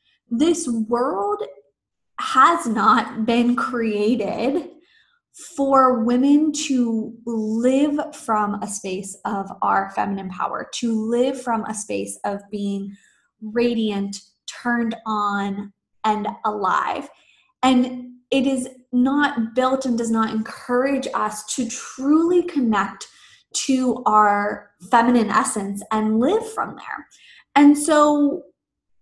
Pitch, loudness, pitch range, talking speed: 235 Hz, -21 LUFS, 210-270 Hz, 110 wpm